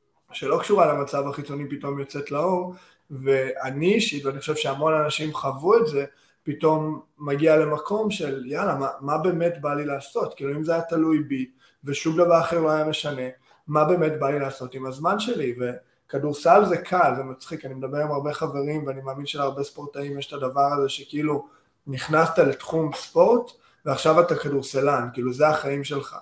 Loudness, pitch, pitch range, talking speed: -24 LUFS, 145 Hz, 140-160 Hz, 170 wpm